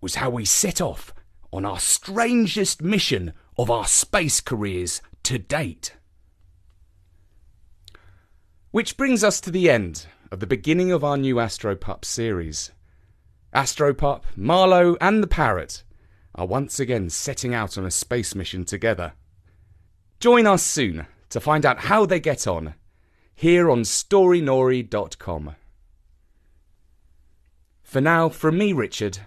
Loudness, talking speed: -21 LUFS, 125 wpm